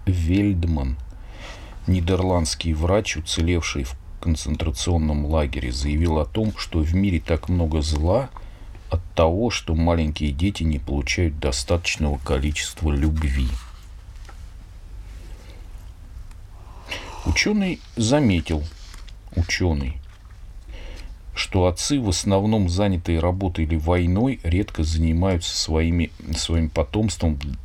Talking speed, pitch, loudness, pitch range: 90 wpm, 85 Hz, -22 LUFS, 80-95 Hz